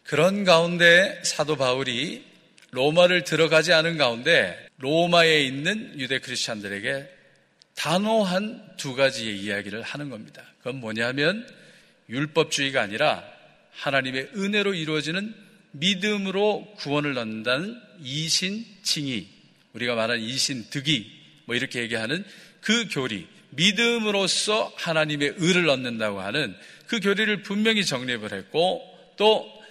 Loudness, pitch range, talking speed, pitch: -23 LUFS, 130-200 Hz, 290 characters per minute, 160 Hz